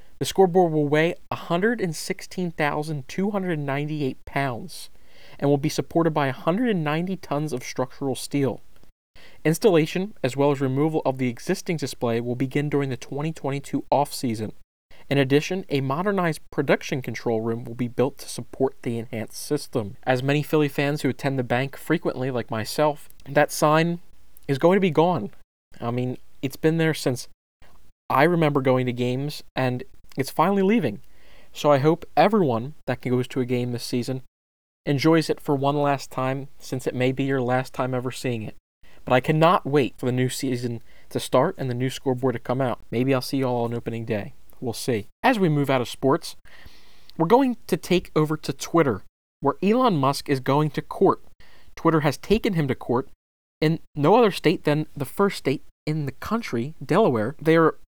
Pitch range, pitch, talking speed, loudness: 125-160 Hz, 140 Hz, 180 wpm, -24 LUFS